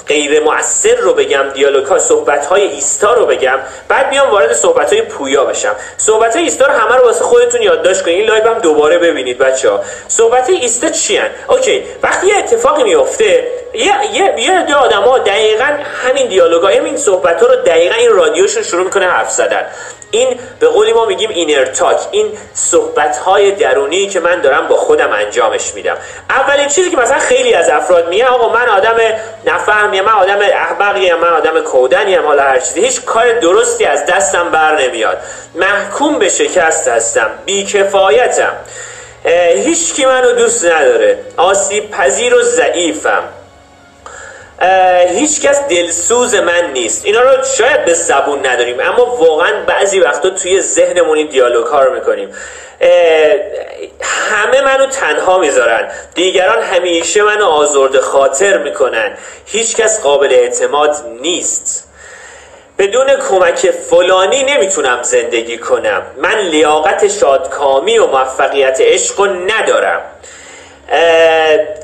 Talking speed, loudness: 145 wpm, -10 LUFS